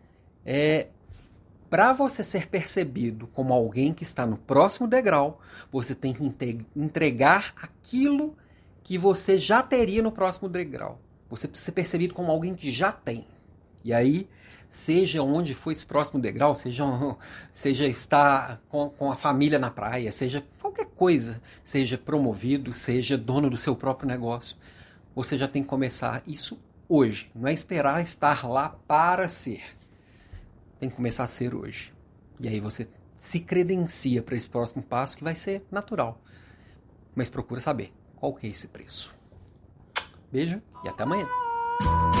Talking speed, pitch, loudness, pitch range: 150 wpm, 135 Hz, -26 LUFS, 115-165 Hz